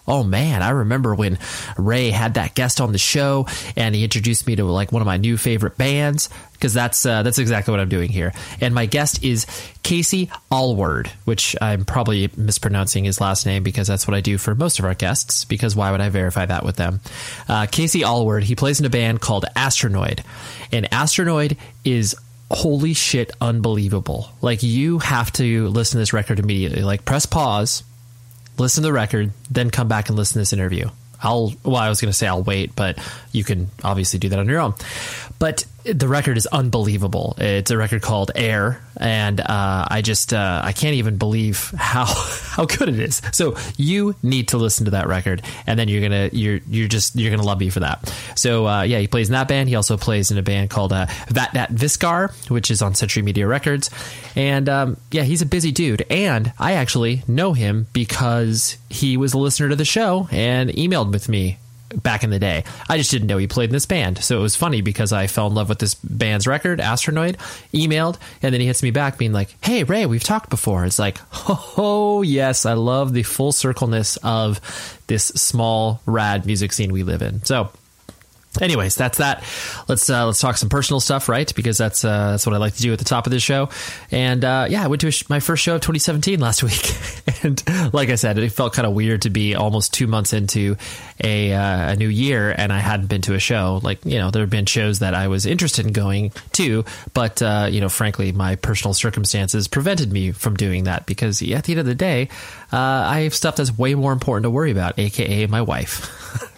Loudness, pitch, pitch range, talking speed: -19 LUFS, 115 Hz, 105-130 Hz, 220 wpm